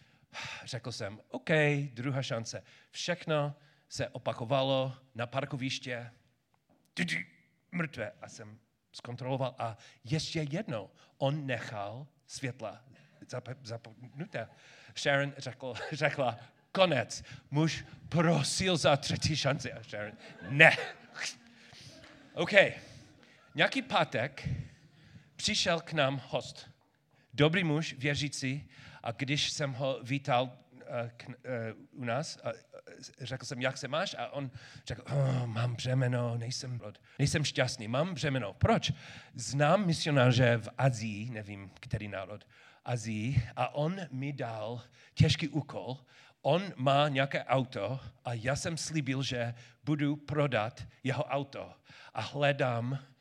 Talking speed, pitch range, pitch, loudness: 115 wpm, 120-145 Hz, 135 Hz, -32 LUFS